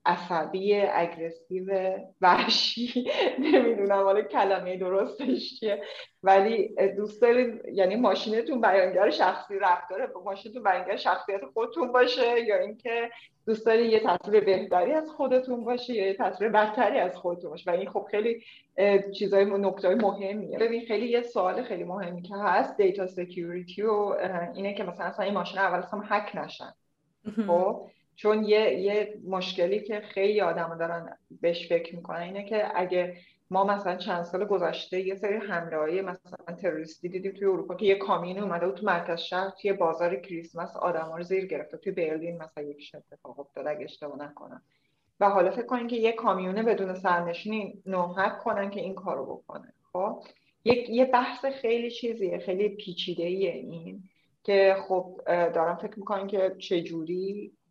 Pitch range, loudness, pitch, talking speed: 175-210 Hz, -27 LUFS, 195 Hz, 150 wpm